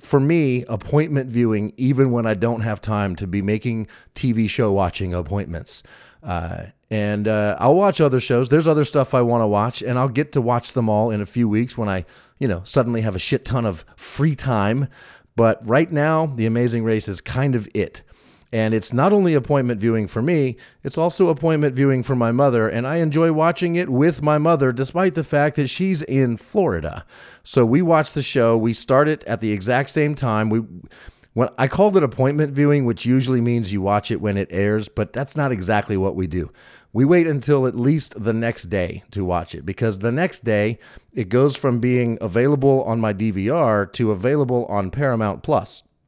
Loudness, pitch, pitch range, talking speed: -20 LUFS, 120 Hz, 110-140 Hz, 205 wpm